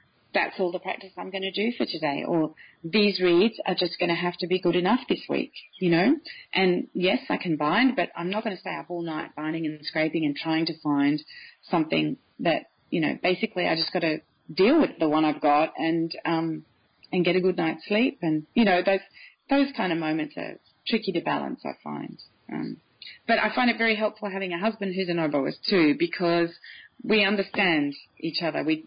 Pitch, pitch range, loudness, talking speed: 175 Hz, 160-200 Hz, -25 LUFS, 210 wpm